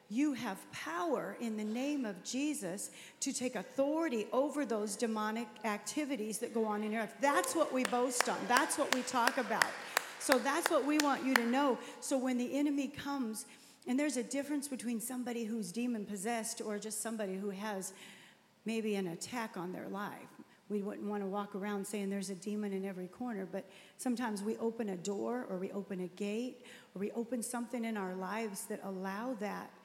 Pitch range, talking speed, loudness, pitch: 205-255 Hz, 195 wpm, -37 LUFS, 225 Hz